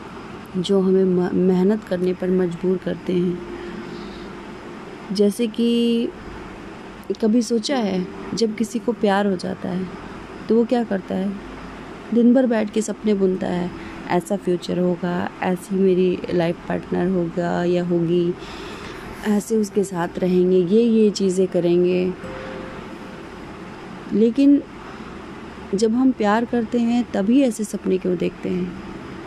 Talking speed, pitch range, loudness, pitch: 125 wpm, 180-220 Hz, -20 LUFS, 190 Hz